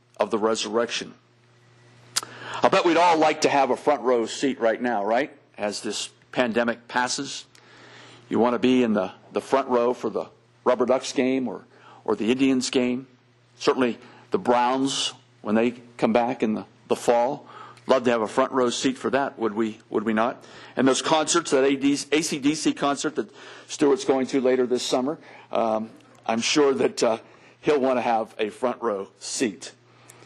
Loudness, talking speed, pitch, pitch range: -24 LUFS, 180 wpm, 125 Hz, 120-135 Hz